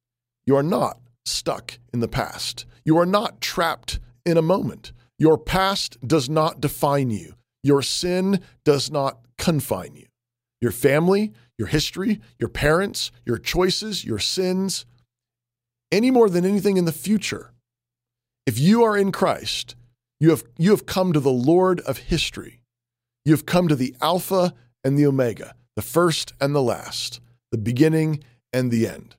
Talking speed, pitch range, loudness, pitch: 160 wpm, 120-175 Hz, -22 LUFS, 135 Hz